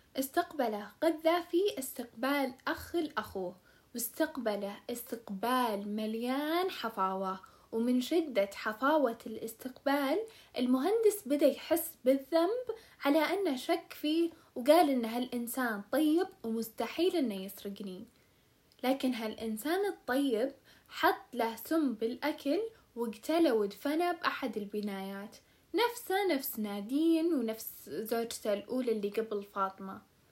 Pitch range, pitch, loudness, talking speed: 225-320 Hz, 260 Hz, -33 LUFS, 95 wpm